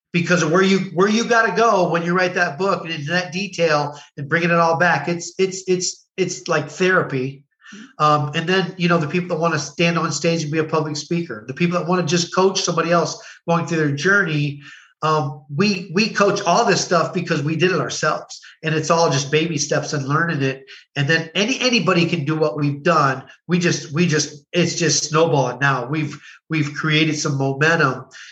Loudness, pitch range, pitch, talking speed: -19 LUFS, 155-180 Hz, 165 Hz, 220 wpm